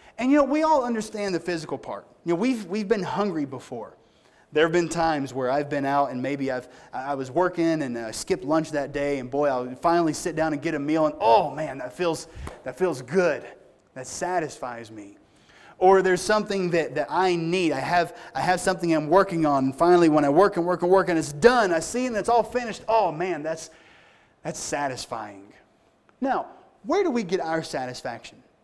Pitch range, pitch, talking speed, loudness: 145-190 Hz, 170 Hz, 215 wpm, -24 LUFS